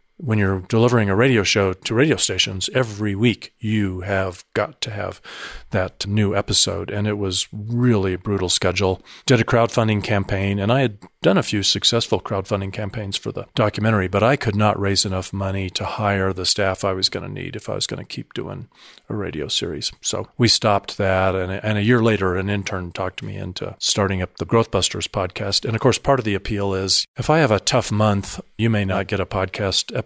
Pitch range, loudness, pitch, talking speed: 95-110 Hz, -20 LUFS, 100 Hz, 215 wpm